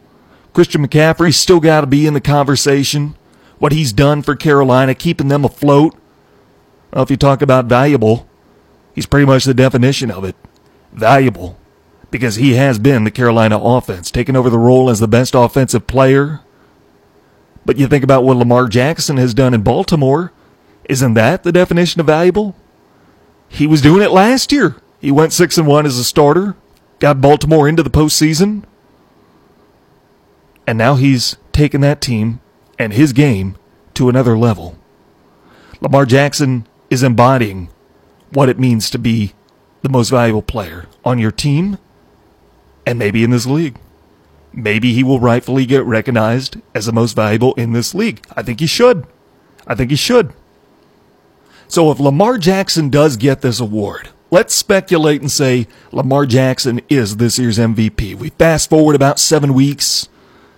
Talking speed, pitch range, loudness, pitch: 160 wpm, 120-150 Hz, -12 LUFS, 135 Hz